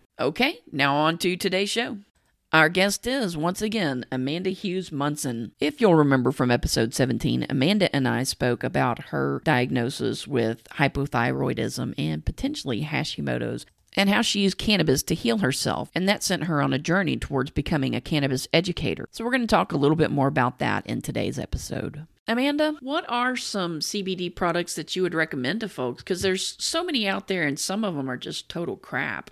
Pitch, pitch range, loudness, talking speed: 165 Hz, 135-200 Hz, -25 LUFS, 190 wpm